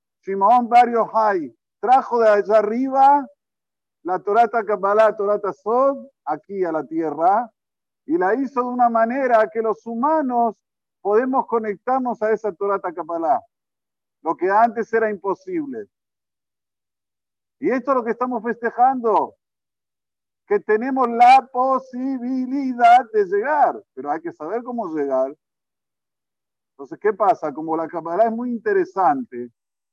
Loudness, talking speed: -20 LUFS, 130 wpm